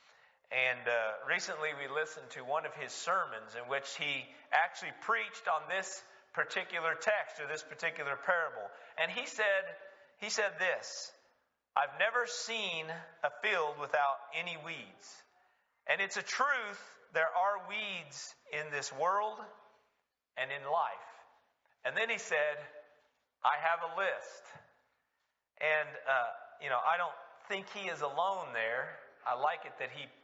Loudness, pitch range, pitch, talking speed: -35 LUFS, 150-220 Hz, 185 Hz, 145 wpm